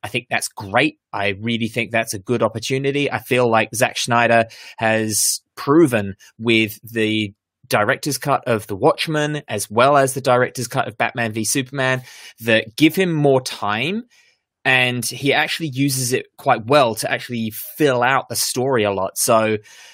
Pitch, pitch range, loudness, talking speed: 120 Hz, 110-135 Hz, -19 LUFS, 170 wpm